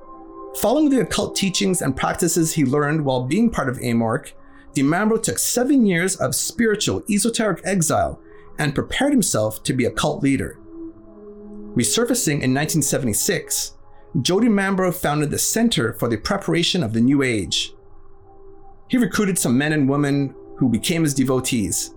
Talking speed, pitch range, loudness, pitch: 150 wpm, 135-210 Hz, -20 LUFS, 170 Hz